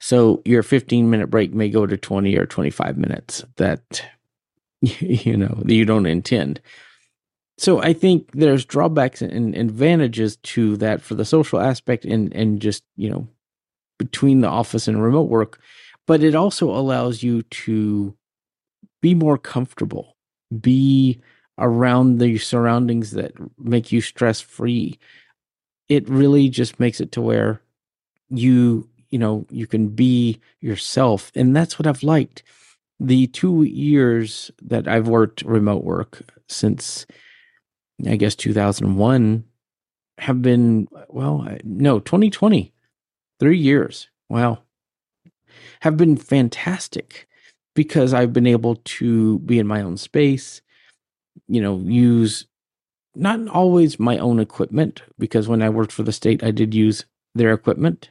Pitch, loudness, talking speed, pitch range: 120 Hz, -18 LUFS, 135 wpm, 110-140 Hz